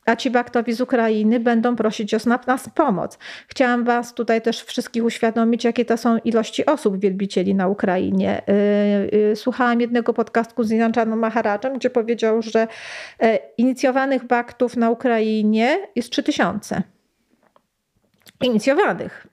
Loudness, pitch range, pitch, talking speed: -20 LUFS, 220-245 Hz, 230 Hz, 125 wpm